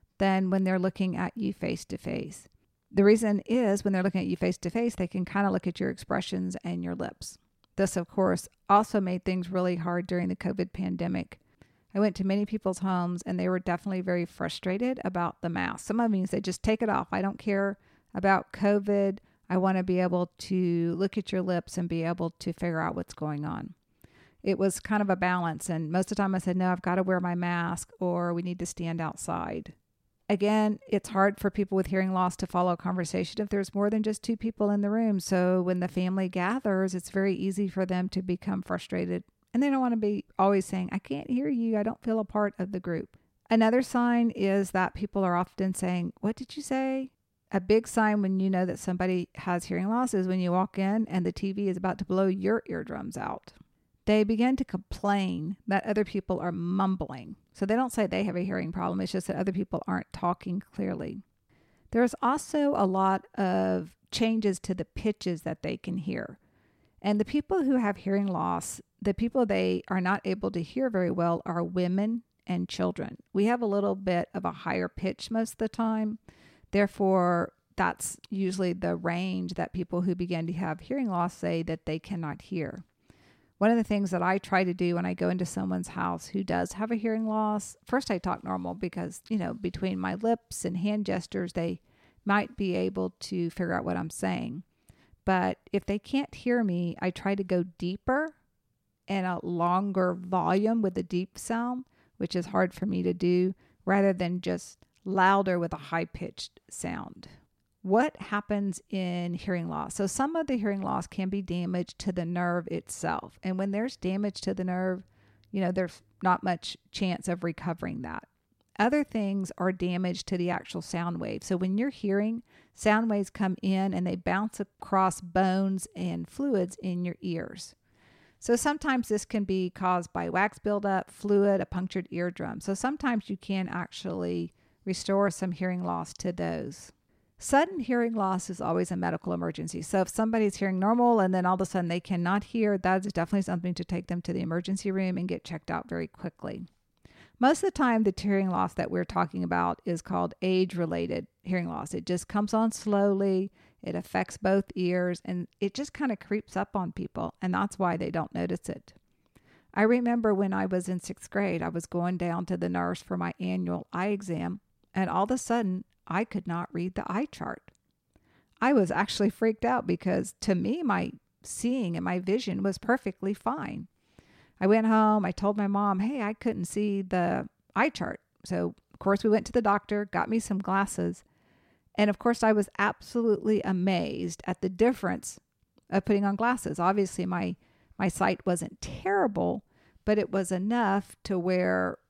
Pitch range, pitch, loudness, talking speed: 175-205 Hz, 190 Hz, -29 LUFS, 200 wpm